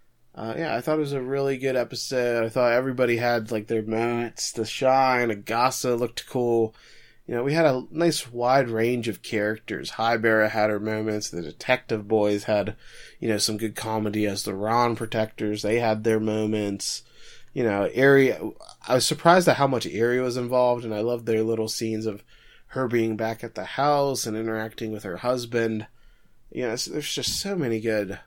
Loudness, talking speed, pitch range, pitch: -24 LUFS, 195 wpm, 110-125 Hz, 115 Hz